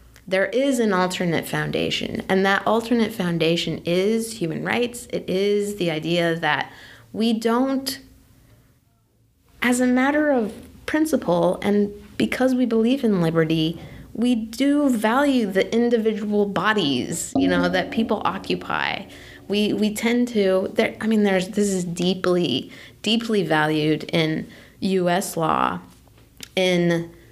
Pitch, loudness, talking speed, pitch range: 195 Hz, -22 LUFS, 125 wpm, 165-230 Hz